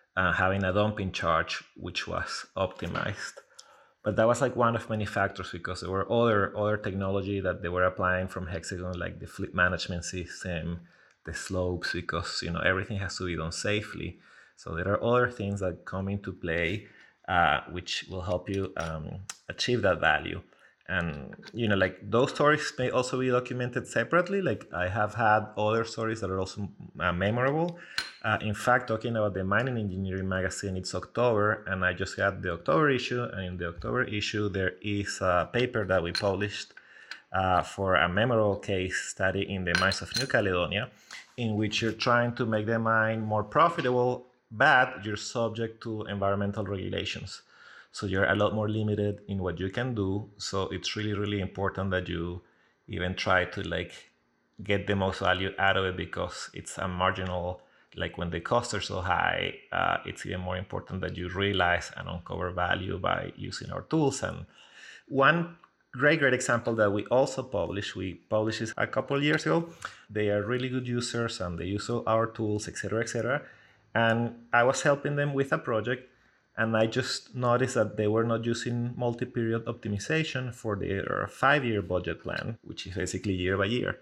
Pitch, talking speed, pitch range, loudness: 105 Hz, 185 wpm, 95-115 Hz, -29 LUFS